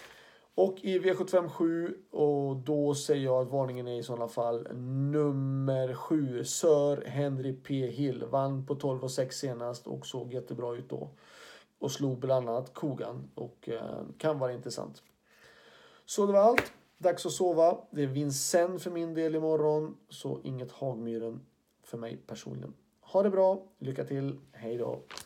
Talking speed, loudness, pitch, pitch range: 160 wpm, -31 LUFS, 140 Hz, 125-160 Hz